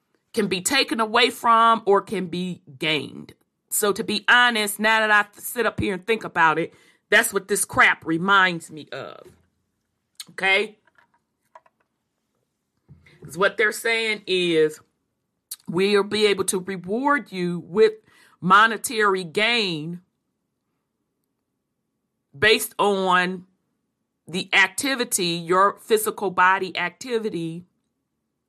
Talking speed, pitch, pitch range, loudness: 110 wpm, 195 Hz, 175-220 Hz, -20 LUFS